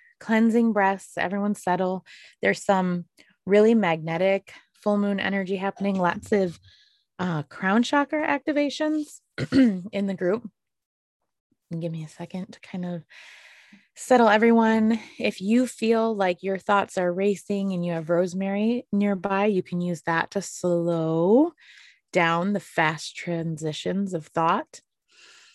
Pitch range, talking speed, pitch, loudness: 175-225 Hz, 130 wpm, 195 Hz, -24 LUFS